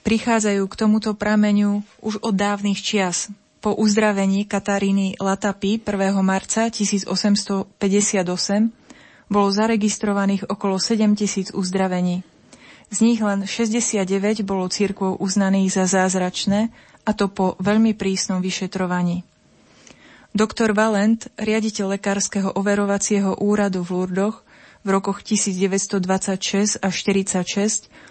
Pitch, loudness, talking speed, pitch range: 200 Hz, -20 LUFS, 100 wpm, 195-215 Hz